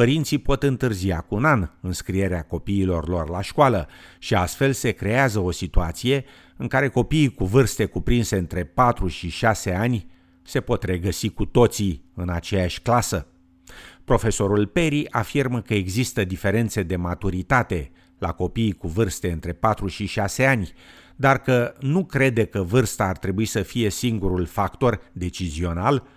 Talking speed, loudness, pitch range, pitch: 150 wpm, -23 LUFS, 90-120 Hz, 100 Hz